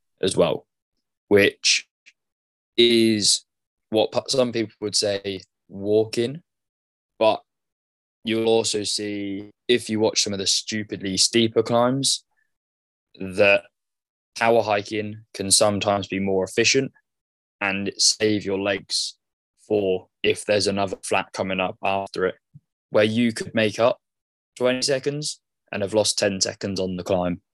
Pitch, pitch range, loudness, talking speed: 105 Hz, 95-115 Hz, -22 LUFS, 130 wpm